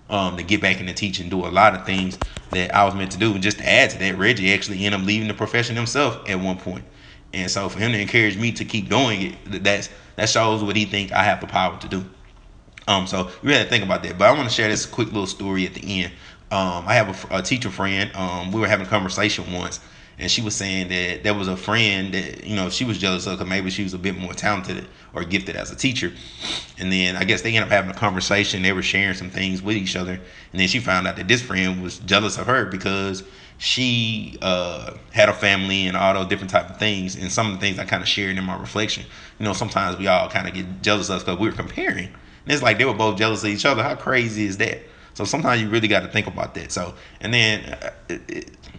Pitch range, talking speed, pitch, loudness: 95-105 Hz, 270 wpm, 100 Hz, -21 LUFS